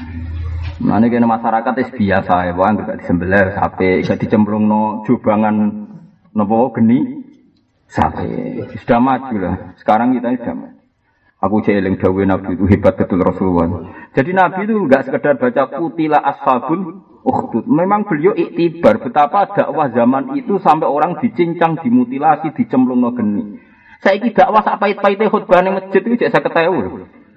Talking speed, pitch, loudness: 130 wpm, 170 Hz, -15 LUFS